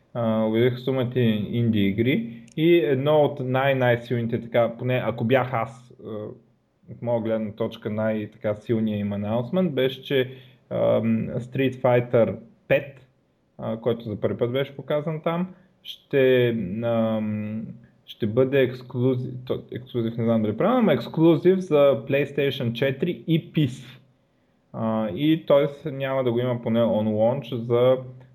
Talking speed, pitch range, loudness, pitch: 135 wpm, 115-140 Hz, -23 LUFS, 125 Hz